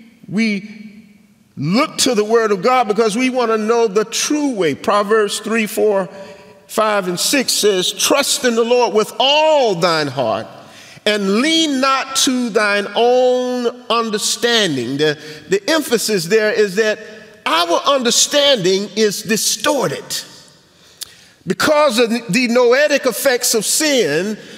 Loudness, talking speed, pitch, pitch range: -15 LUFS, 130 wpm, 225 Hz, 205-250 Hz